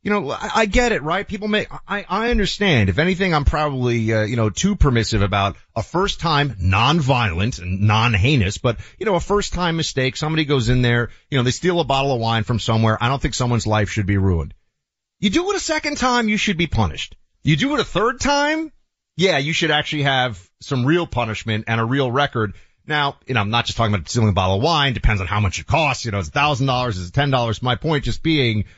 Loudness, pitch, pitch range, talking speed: -19 LUFS, 130 Hz, 110-165 Hz, 245 wpm